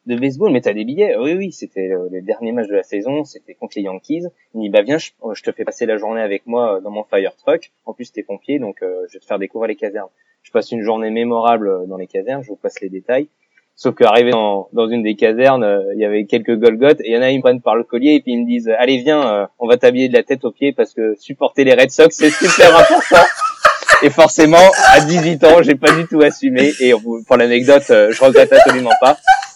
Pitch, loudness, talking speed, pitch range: 130 Hz, -12 LUFS, 260 wpm, 110-160 Hz